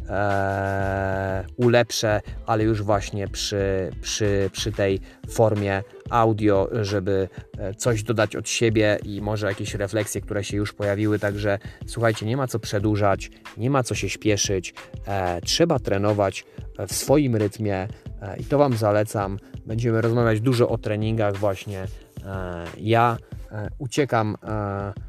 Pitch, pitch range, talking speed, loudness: 105 Hz, 100-115 Hz, 135 wpm, -23 LUFS